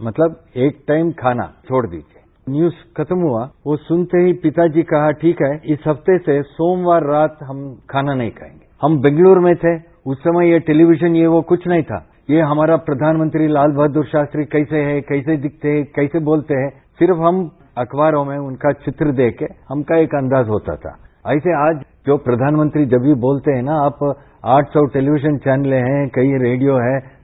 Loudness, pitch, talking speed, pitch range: -16 LUFS, 150 Hz, 185 wpm, 135-160 Hz